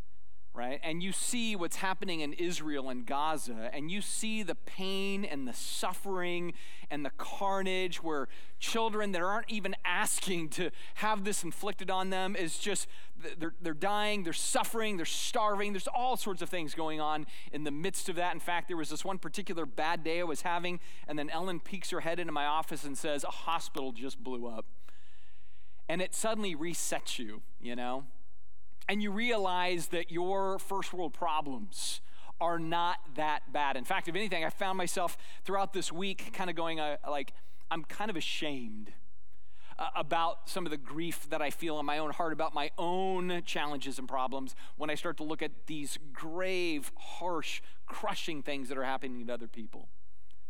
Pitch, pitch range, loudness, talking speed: 165 Hz, 145-190 Hz, -35 LUFS, 185 wpm